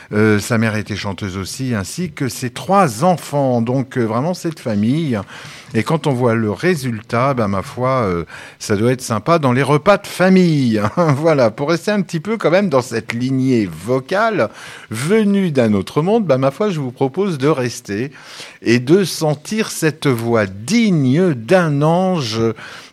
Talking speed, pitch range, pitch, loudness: 180 wpm, 115-170 Hz, 135 Hz, -17 LUFS